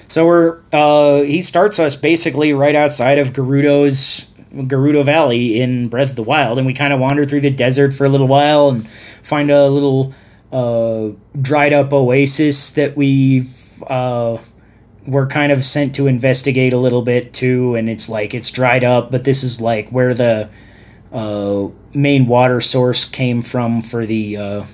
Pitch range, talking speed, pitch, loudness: 115-140 Hz, 170 wpm, 130 Hz, -13 LUFS